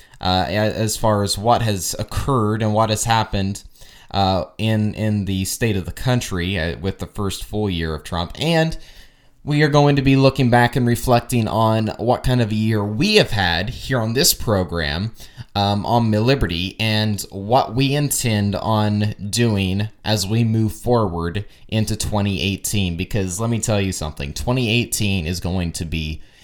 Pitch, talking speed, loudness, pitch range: 105 Hz, 170 wpm, -19 LUFS, 95-120 Hz